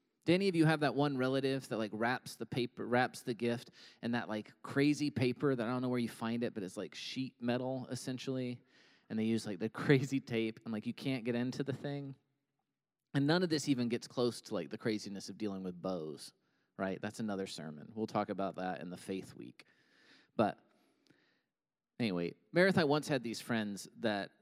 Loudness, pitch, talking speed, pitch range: -36 LUFS, 120 Hz, 210 wpm, 110-135 Hz